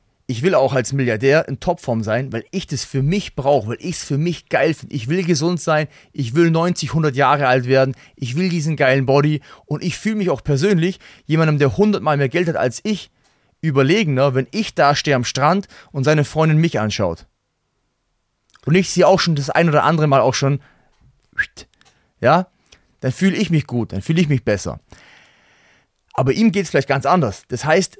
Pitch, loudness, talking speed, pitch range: 150 Hz, -18 LUFS, 205 wpm, 135-170 Hz